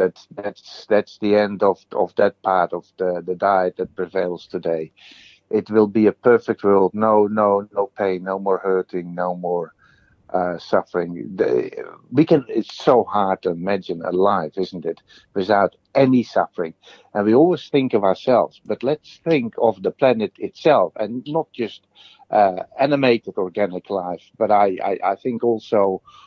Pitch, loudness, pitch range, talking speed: 105 Hz, -20 LUFS, 90-120 Hz, 170 wpm